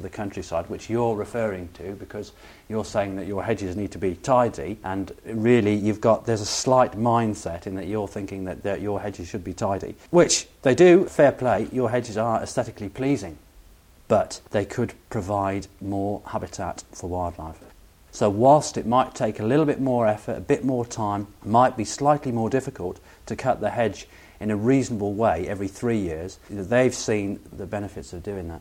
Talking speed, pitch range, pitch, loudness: 190 wpm, 95-115 Hz, 105 Hz, -24 LUFS